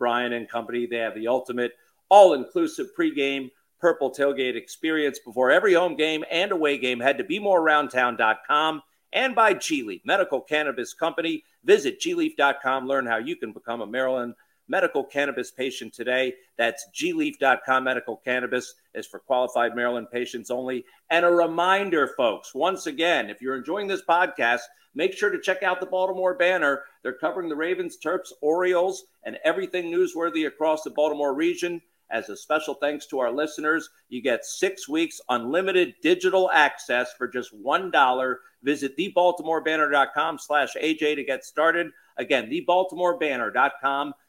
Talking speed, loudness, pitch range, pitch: 155 wpm, -24 LUFS, 130-185 Hz, 155 Hz